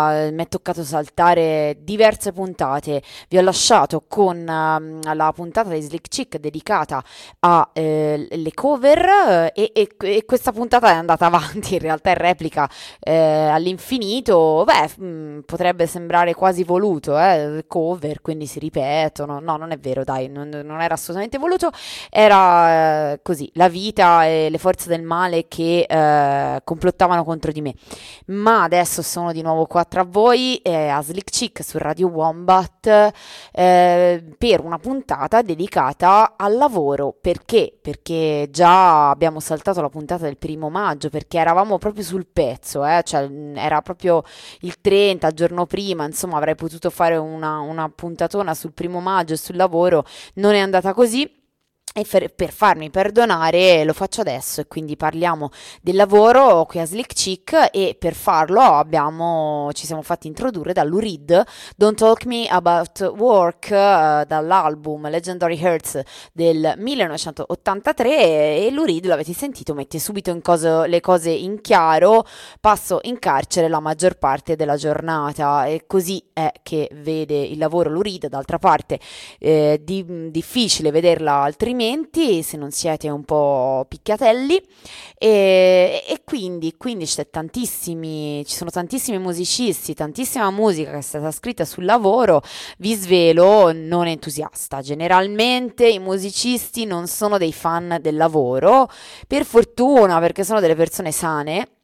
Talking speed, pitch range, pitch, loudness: 150 wpm, 155-195 Hz, 170 Hz, -18 LUFS